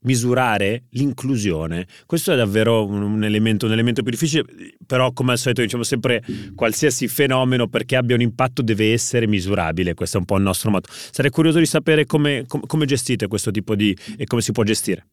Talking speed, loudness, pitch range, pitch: 195 wpm, -19 LUFS, 105-135 Hz, 120 Hz